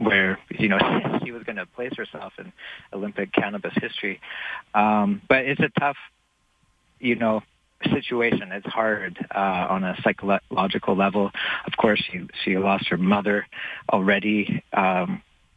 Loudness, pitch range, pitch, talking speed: -23 LUFS, 100-115 Hz, 105 Hz, 145 wpm